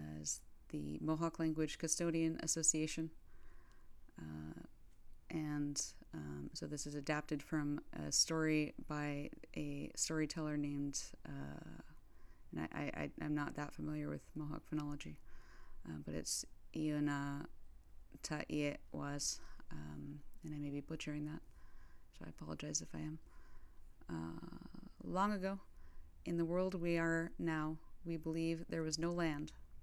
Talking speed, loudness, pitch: 125 wpm, -42 LUFS, 145 Hz